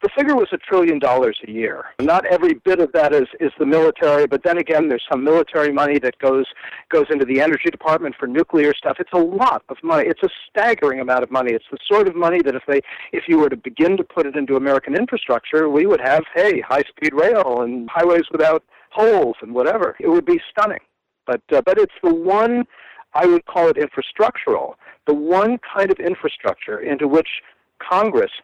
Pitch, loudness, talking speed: 175 Hz, -18 LUFS, 210 wpm